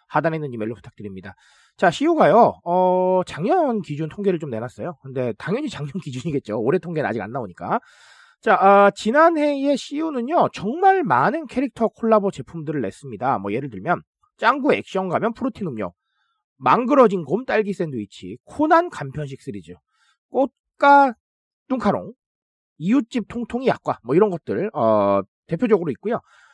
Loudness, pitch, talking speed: -20 LUFS, 195 Hz, 330 characters per minute